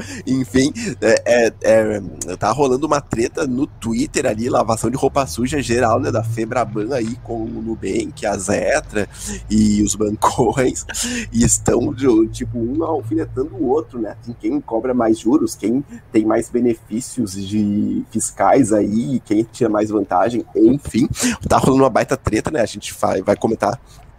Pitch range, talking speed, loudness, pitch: 105-130 Hz, 155 wpm, -18 LUFS, 115 Hz